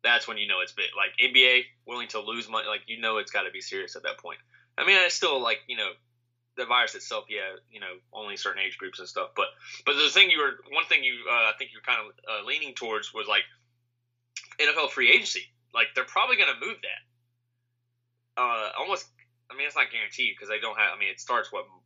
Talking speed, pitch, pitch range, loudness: 240 wpm, 120 Hz, 120-125 Hz, -25 LUFS